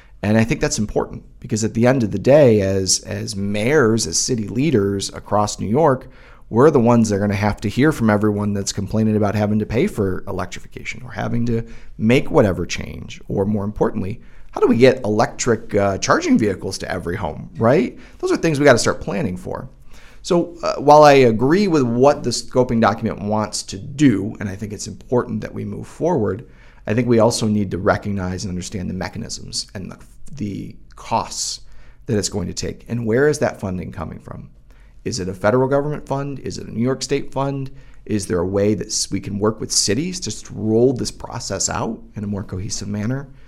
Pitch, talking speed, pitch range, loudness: 110 Hz, 210 wpm, 100-125 Hz, -19 LUFS